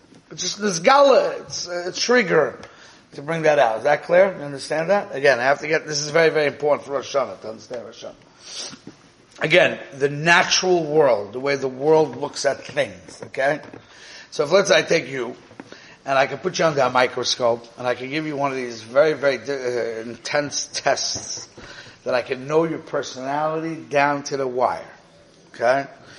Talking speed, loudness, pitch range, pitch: 190 wpm, -20 LUFS, 135-165 Hz, 145 Hz